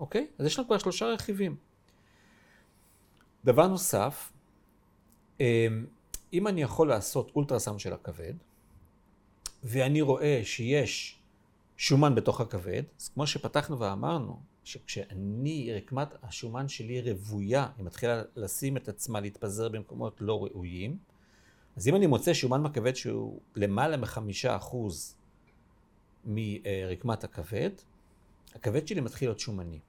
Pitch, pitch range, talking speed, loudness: 115 Hz, 100-140 Hz, 115 wpm, -31 LUFS